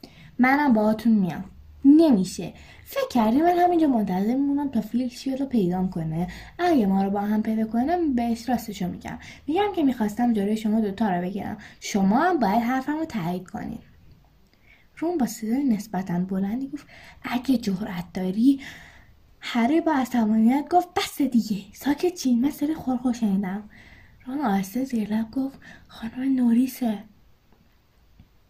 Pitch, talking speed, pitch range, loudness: 235 Hz, 140 wpm, 210-275 Hz, -24 LUFS